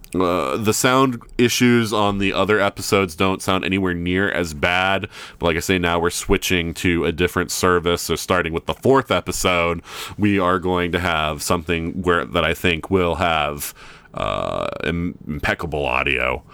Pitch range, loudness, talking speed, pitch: 85-95 Hz, -19 LUFS, 170 wpm, 90 Hz